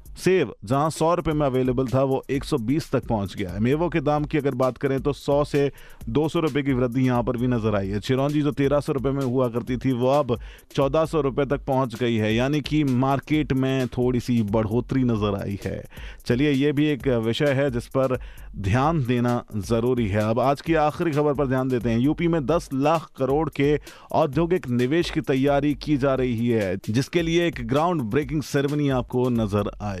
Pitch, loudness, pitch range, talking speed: 135 Hz, -23 LUFS, 120-150 Hz, 210 wpm